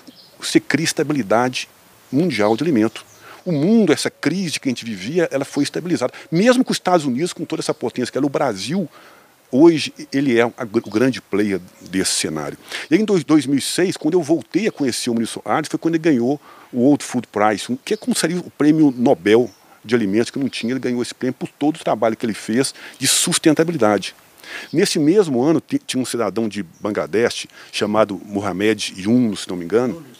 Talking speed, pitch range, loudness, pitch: 200 wpm, 115-165 Hz, -19 LUFS, 135 Hz